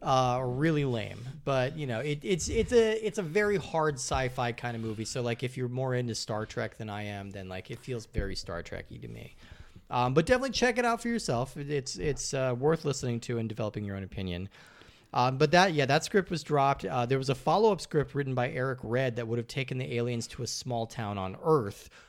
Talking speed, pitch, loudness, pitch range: 235 wpm, 130 Hz, -30 LUFS, 115-150 Hz